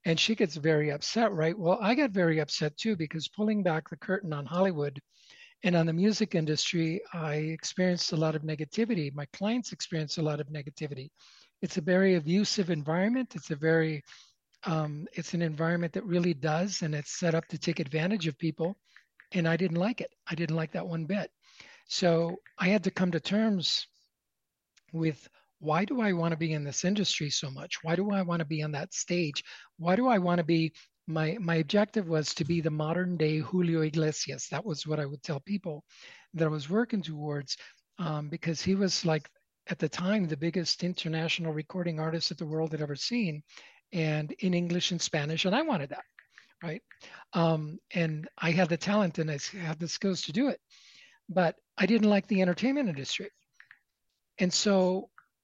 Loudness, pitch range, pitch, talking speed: -30 LUFS, 155-190 Hz, 170 Hz, 195 wpm